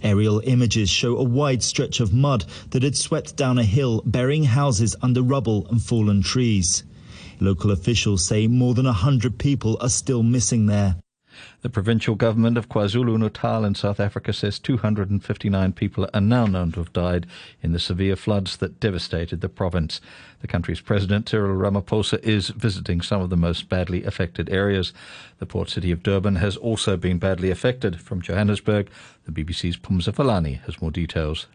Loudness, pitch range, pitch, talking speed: -22 LUFS, 95-120 Hz, 105 Hz, 175 wpm